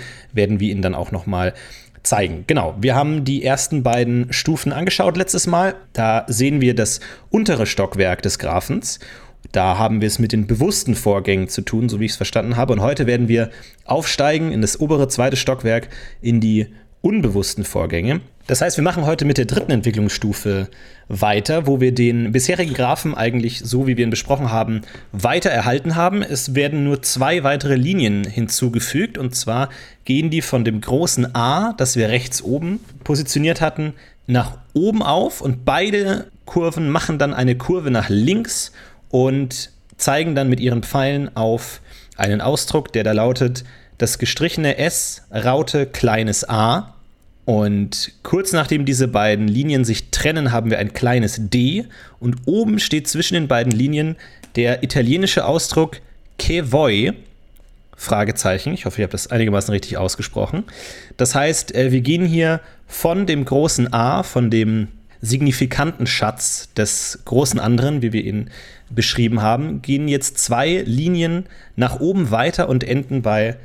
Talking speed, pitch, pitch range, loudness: 160 wpm, 125 Hz, 110-145 Hz, -18 LUFS